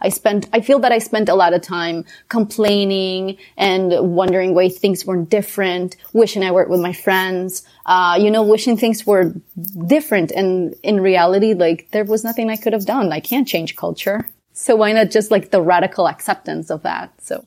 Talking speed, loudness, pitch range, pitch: 195 wpm, -16 LUFS, 180-220 Hz, 195 Hz